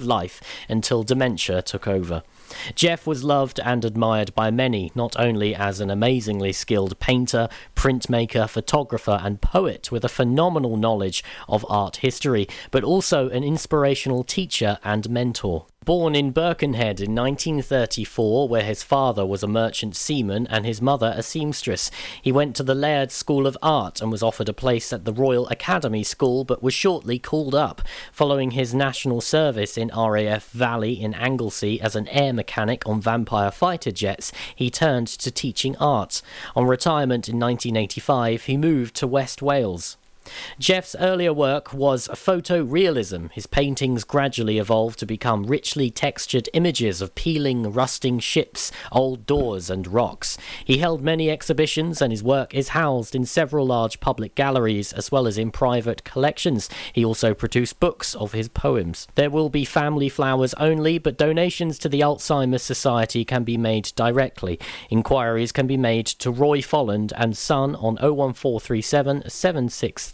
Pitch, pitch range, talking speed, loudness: 125 Hz, 110-140 Hz, 155 wpm, -22 LUFS